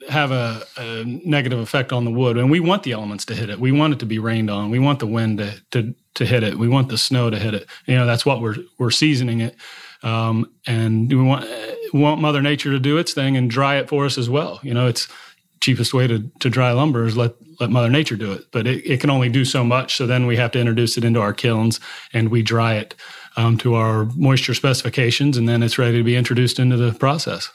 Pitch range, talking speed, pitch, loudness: 115-135 Hz, 260 wpm, 125 Hz, -19 LUFS